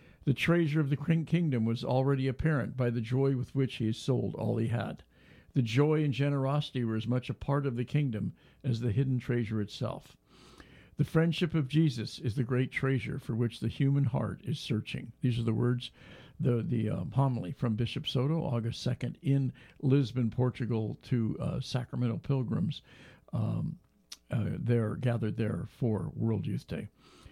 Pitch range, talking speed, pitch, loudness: 120-140 Hz, 175 wpm, 130 Hz, -32 LUFS